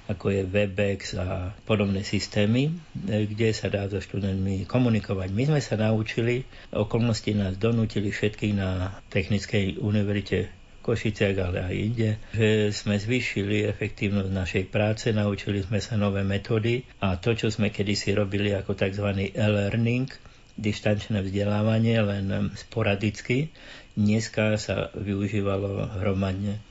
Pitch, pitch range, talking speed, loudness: 105 Hz, 100-110 Hz, 125 wpm, -26 LUFS